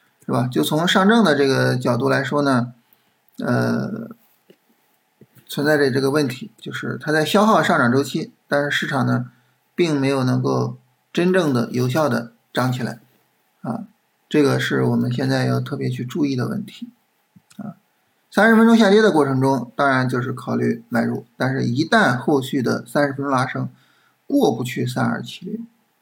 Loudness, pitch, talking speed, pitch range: -19 LUFS, 135 Hz, 245 characters per minute, 120-155 Hz